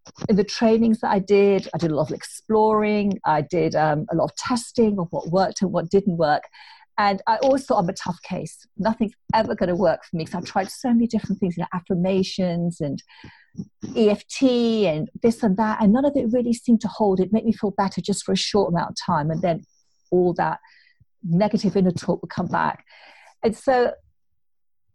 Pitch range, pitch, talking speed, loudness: 180-225 Hz, 200 Hz, 215 wpm, -22 LUFS